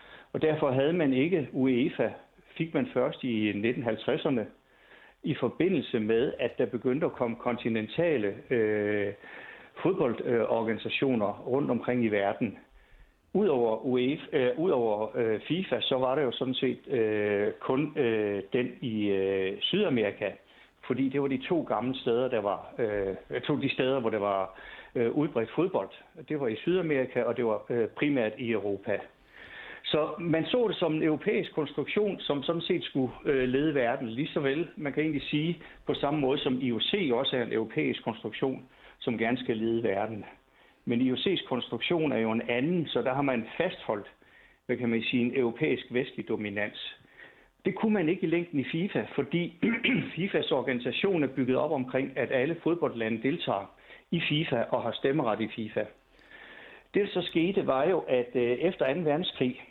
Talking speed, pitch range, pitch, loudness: 165 wpm, 115-155 Hz, 130 Hz, -29 LUFS